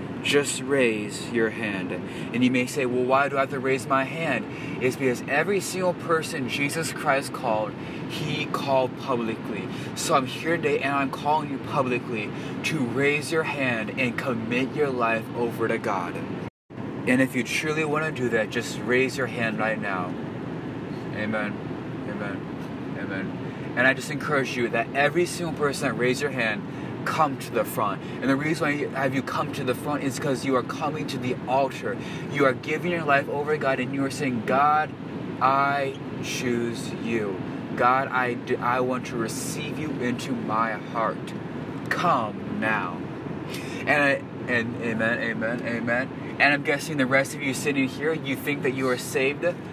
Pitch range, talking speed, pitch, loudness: 125-145 Hz, 180 wpm, 135 Hz, -26 LUFS